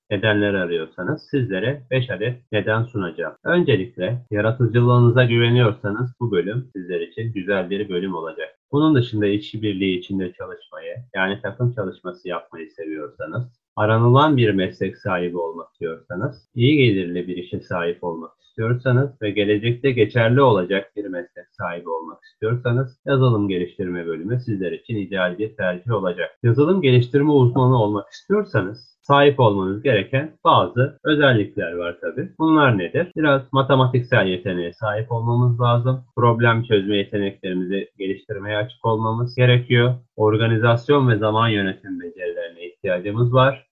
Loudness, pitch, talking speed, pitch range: -20 LUFS, 115 Hz, 130 wpm, 100-130 Hz